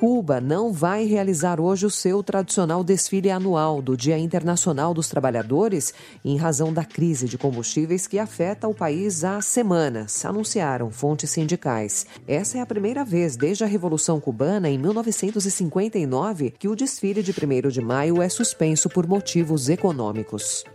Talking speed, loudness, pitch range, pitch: 155 wpm, -23 LUFS, 145-200 Hz, 175 Hz